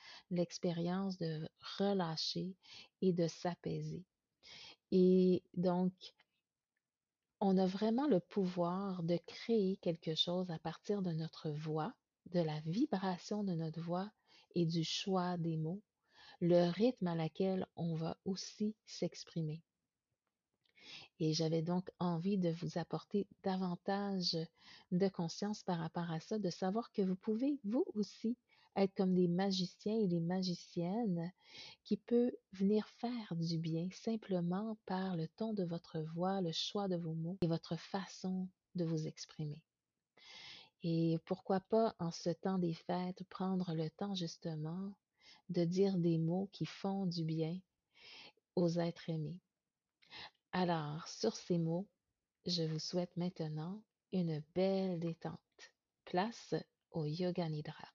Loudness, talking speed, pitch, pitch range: -39 LUFS, 135 wpm, 180 Hz, 165-195 Hz